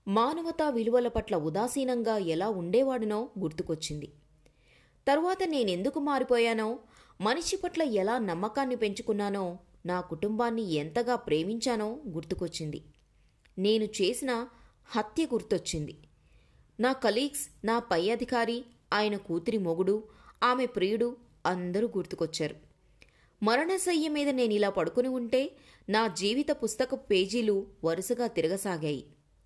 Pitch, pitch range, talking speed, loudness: 220 Hz, 185-245 Hz, 95 wpm, -30 LUFS